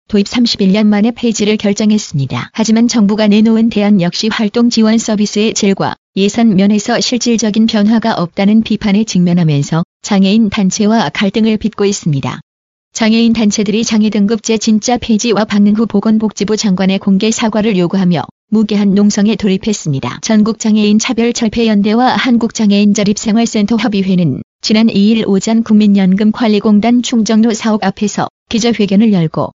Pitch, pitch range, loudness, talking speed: 215 Hz, 200-225 Hz, -11 LUFS, 365 characters per minute